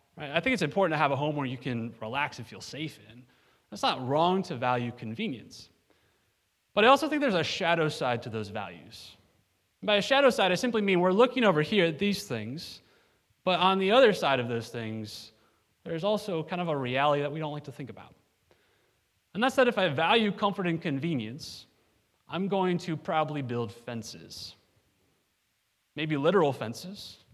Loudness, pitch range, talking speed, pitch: -28 LUFS, 110-180 Hz, 195 wpm, 140 Hz